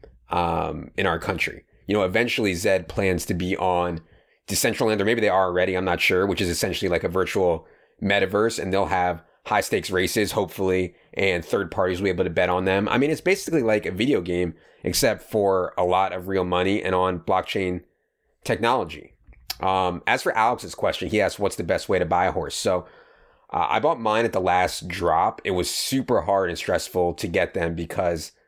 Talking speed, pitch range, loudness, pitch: 205 wpm, 90-110 Hz, -23 LUFS, 95 Hz